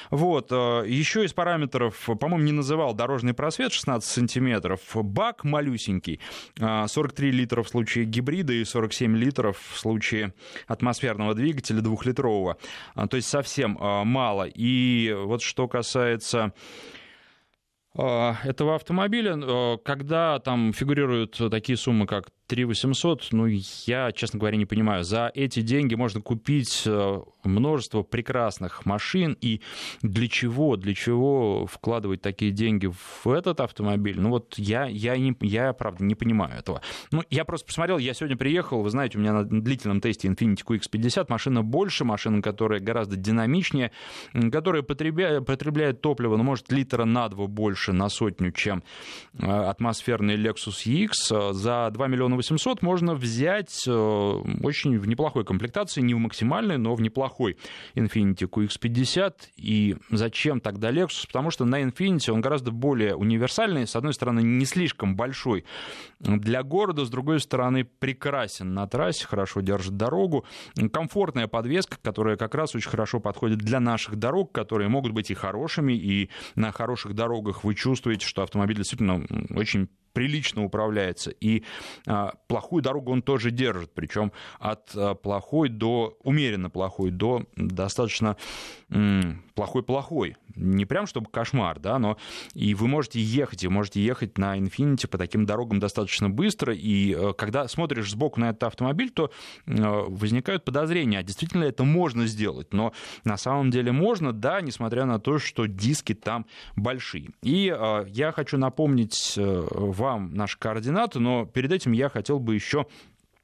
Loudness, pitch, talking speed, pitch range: -26 LUFS, 115 Hz, 145 wpm, 105-135 Hz